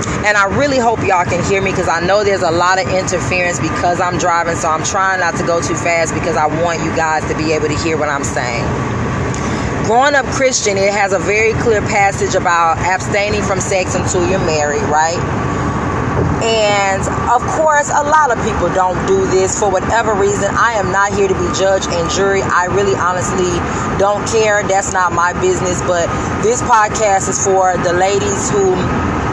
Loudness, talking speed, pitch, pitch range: -14 LUFS, 195 wpm, 185 Hz, 165-200 Hz